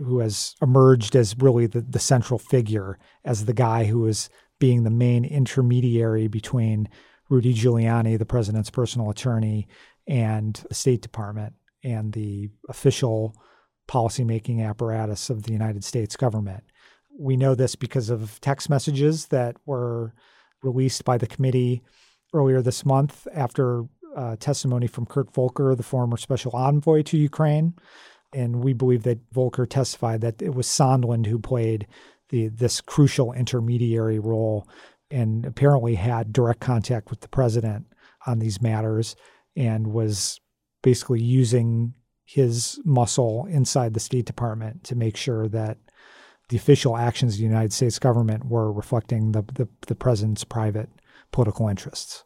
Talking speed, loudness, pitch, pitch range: 145 wpm, -23 LUFS, 120 Hz, 110-130 Hz